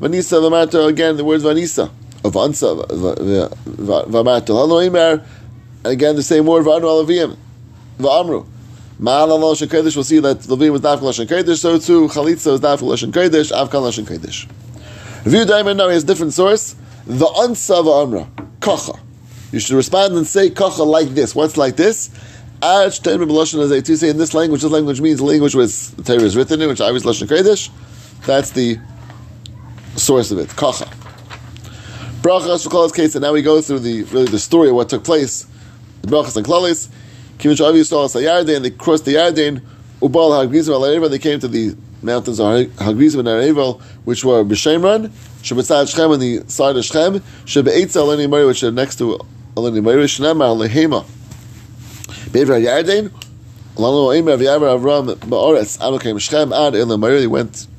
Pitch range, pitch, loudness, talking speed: 120-160 Hz, 140 Hz, -14 LUFS, 165 wpm